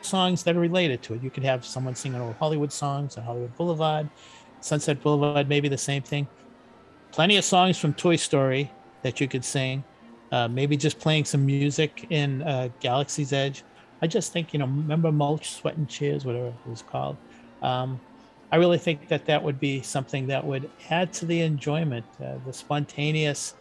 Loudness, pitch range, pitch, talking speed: -26 LUFS, 130-155 Hz, 145 Hz, 190 wpm